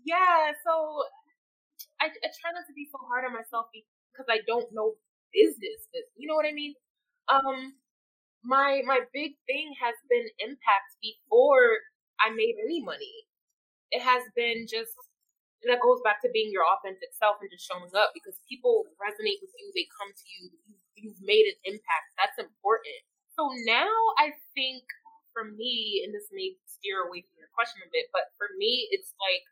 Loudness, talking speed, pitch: -28 LUFS, 180 wpm, 290 Hz